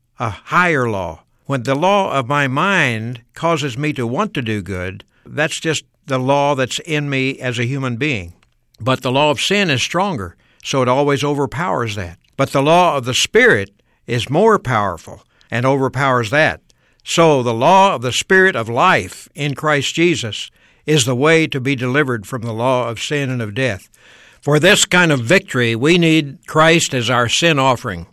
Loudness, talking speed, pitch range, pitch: -16 LUFS, 190 wpm, 120-155 Hz, 135 Hz